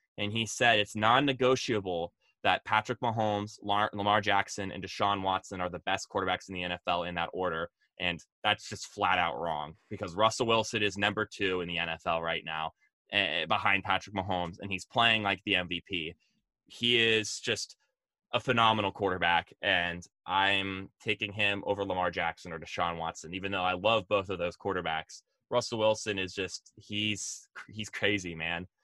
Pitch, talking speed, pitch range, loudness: 100 Hz, 170 wpm, 90-110 Hz, -30 LUFS